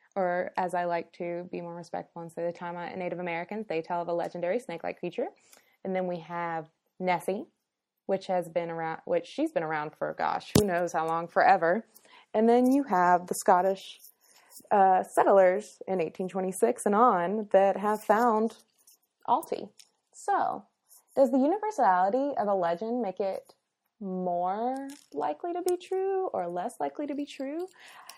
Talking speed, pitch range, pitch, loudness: 165 wpm, 175-245 Hz, 190 Hz, -28 LUFS